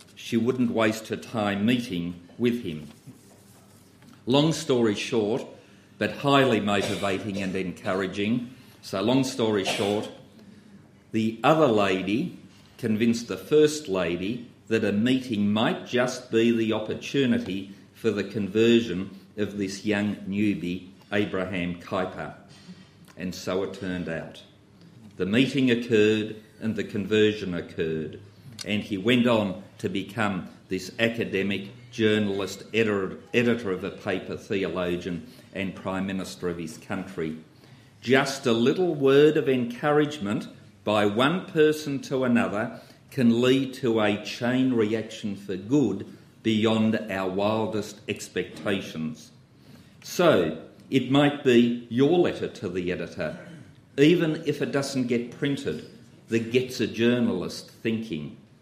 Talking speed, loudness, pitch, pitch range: 125 wpm, -26 LUFS, 110 Hz, 100-125 Hz